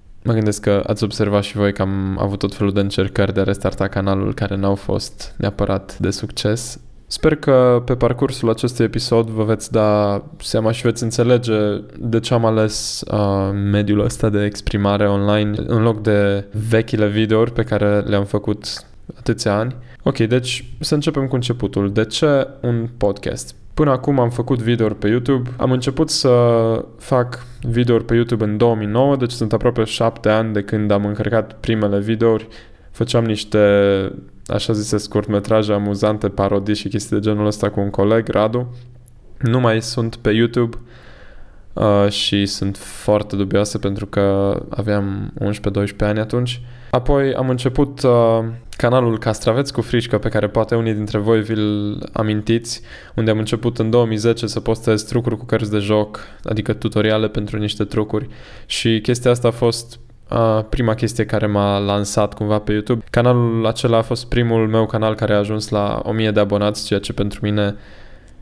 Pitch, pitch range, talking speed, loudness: 110 Hz, 105-120 Hz, 165 wpm, -18 LUFS